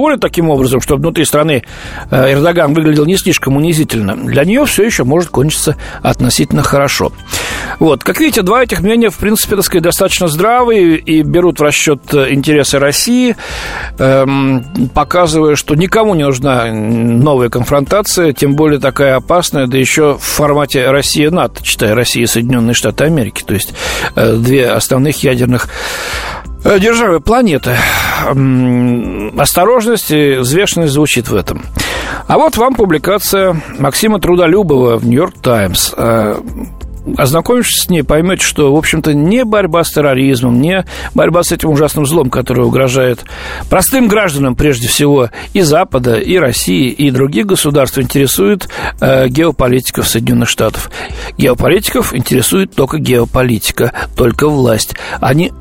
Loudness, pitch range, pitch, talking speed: -10 LUFS, 130-175 Hz, 145 Hz, 130 wpm